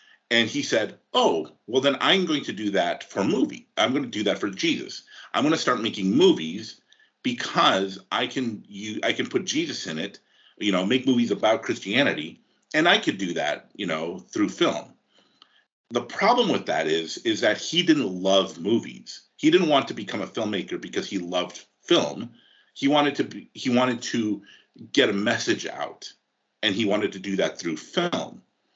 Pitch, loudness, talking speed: 130 Hz, -24 LUFS, 195 wpm